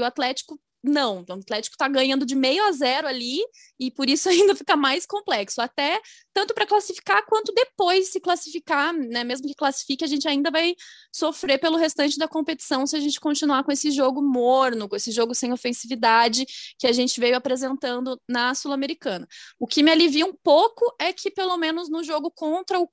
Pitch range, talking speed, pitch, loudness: 260-345 Hz, 195 wpm, 290 Hz, -22 LUFS